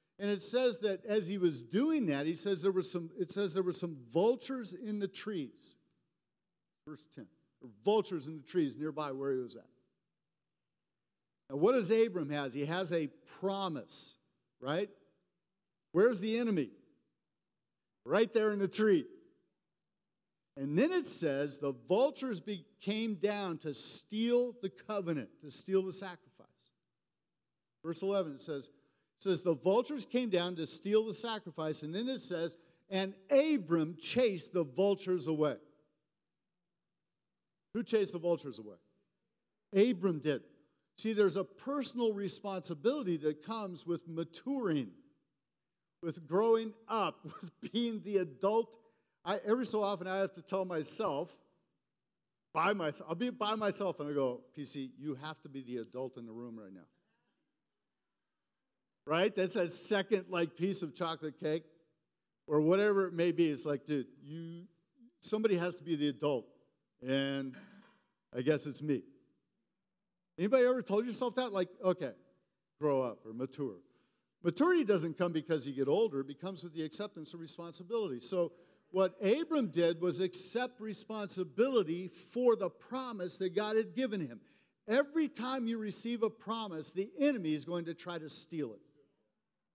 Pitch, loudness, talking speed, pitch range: 180 Hz, -35 LUFS, 155 wpm, 155-215 Hz